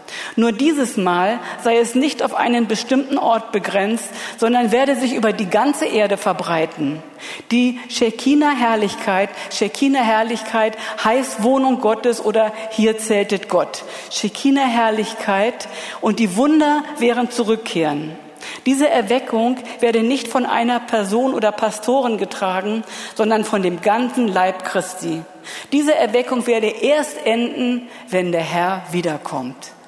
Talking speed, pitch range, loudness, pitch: 125 wpm, 205-245 Hz, -18 LUFS, 225 Hz